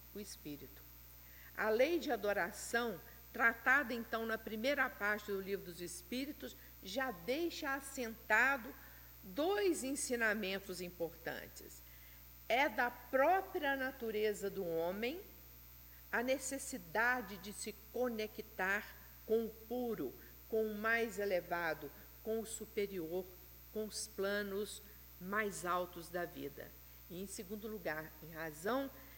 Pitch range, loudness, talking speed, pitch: 175-245 Hz, -39 LUFS, 115 wpm, 215 Hz